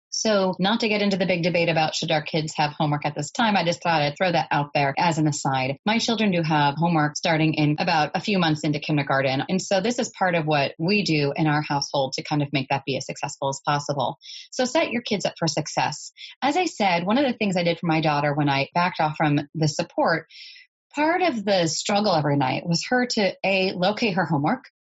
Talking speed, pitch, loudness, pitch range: 245 wpm, 165 Hz, -23 LUFS, 150-195 Hz